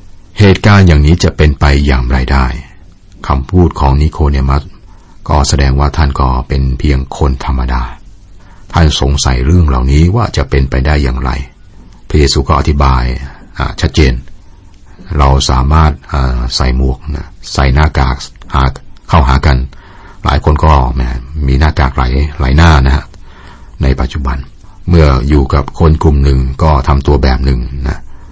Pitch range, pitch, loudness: 65-85 Hz, 70 Hz, -11 LUFS